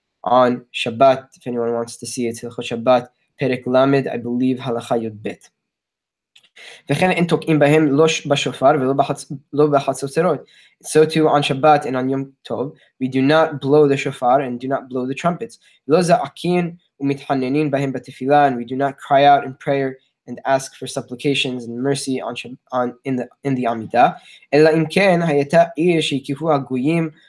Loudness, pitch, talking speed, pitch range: -18 LUFS, 135 Hz, 165 wpm, 130-150 Hz